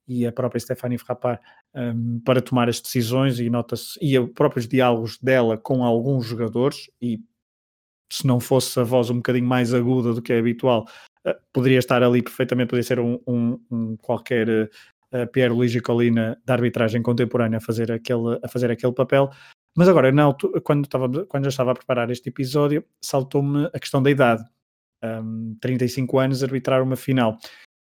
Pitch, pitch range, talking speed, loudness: 125 Hz, 120-130 Hz, 175 wpm, -22 LUFS